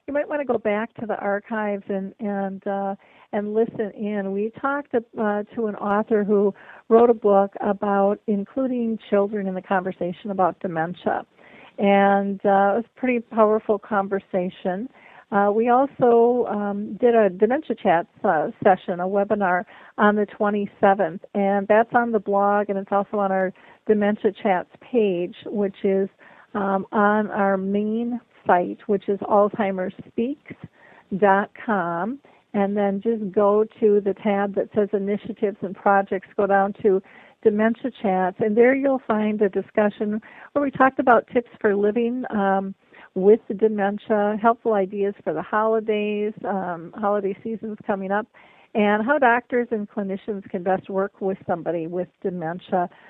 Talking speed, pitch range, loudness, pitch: 155 wpm, 195-225 Hz, -22 LUFS, 205 Hz